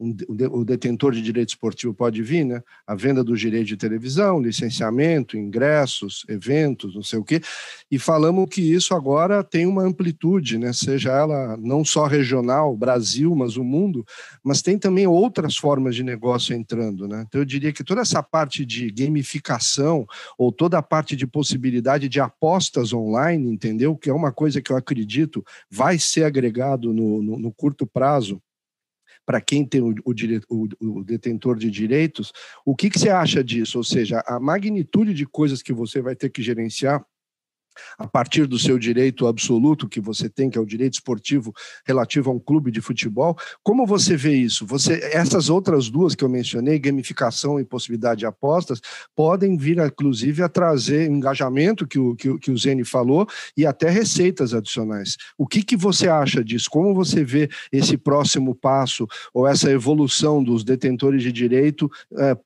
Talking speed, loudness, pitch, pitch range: 175 wpm, -20 LUFS, 135 Hz, 120-155 Hz